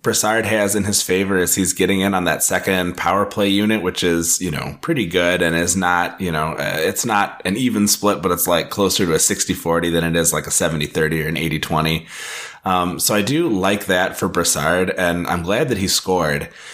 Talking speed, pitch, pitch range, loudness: 220 wpm, 90 Hz, 85-100 Hz, -18 LUFS